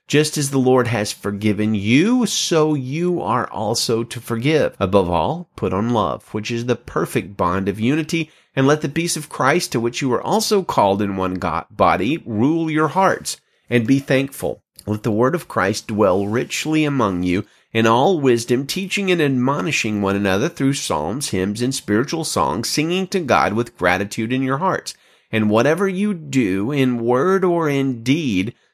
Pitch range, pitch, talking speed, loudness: 105-155 Hz, 130 Hz, 180 wpm, -19 LUFS